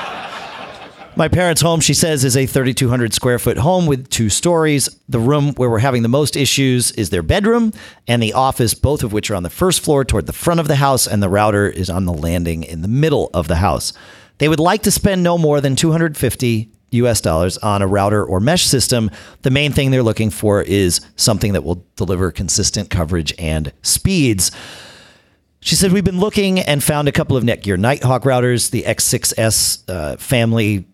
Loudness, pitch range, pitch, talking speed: -15 LUFS, 100-145 Hz, 120 Hz, 200 wpm